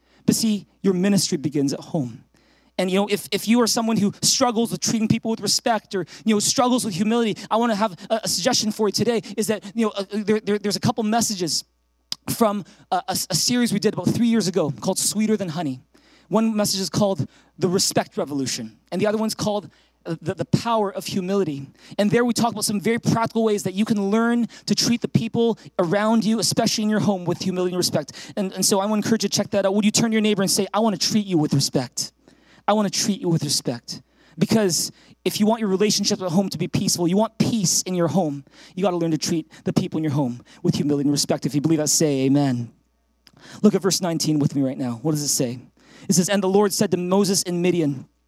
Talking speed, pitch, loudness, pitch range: 250 wpm, 200 Hz, -21 LUFS, 170-215 Hz